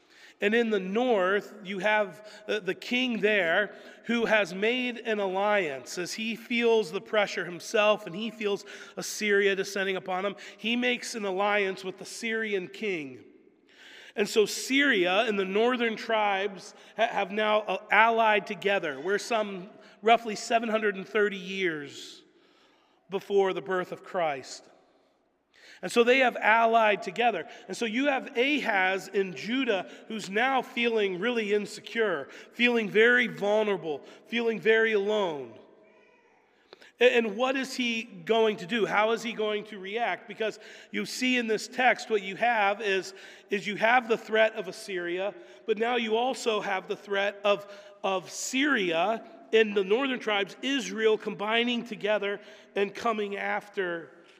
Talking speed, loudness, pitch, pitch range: 145 wpm, -27 LUFS, 215 Hz, 200-230 Hz